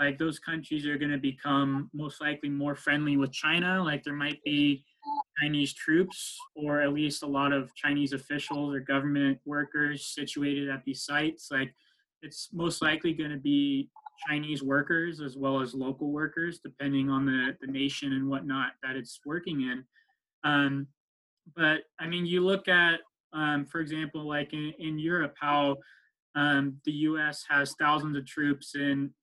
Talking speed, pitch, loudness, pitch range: 170 wpm, 145 Hz, -30 LUFS, 140-155 Hz